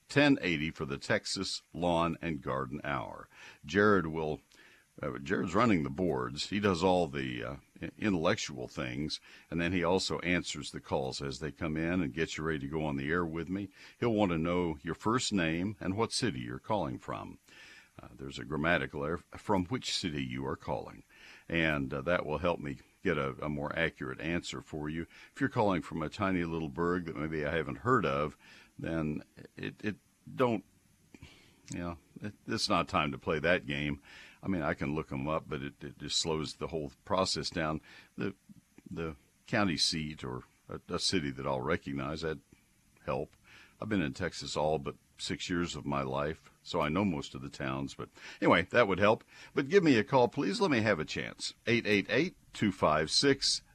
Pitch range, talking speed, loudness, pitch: 70-90 Hz, 195 wpm, -33 LUFS, 80 Hz